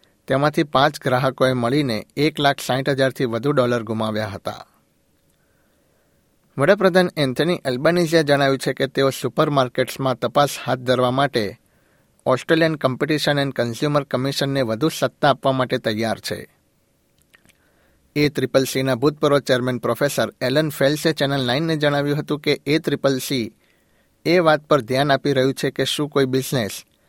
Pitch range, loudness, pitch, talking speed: 130-150 Hz, -20 LUFS, 135 Hz, 135 wpm